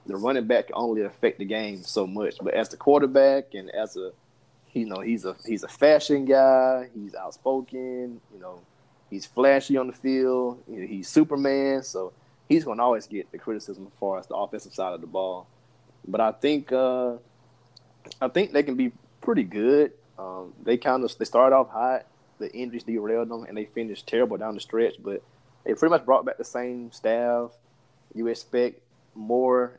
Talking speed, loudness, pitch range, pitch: 195 wpm, -25 LUFS, 110-130 Hz, 120 Hz